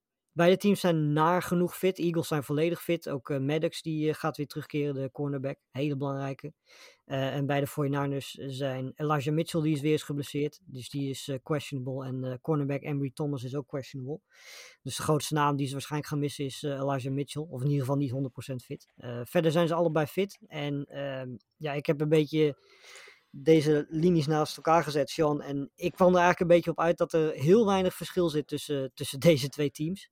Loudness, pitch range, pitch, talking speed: -29 LUFS, 140-165 Hz, 150 Hz, 210 wpm